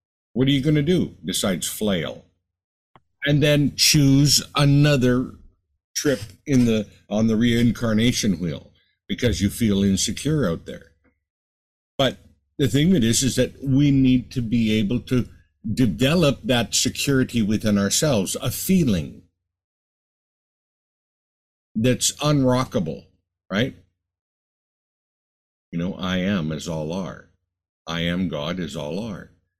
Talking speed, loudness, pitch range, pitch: 125 wpm, -21 LUFS, 90-130 Hz, 110 Hz